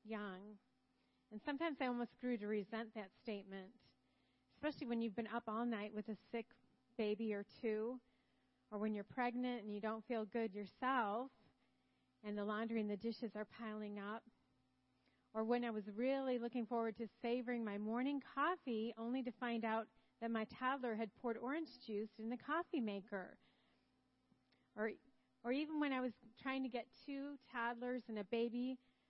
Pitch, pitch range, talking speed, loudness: 230 Hz, 210-245 Hz, 170 wpm, -45 LUFS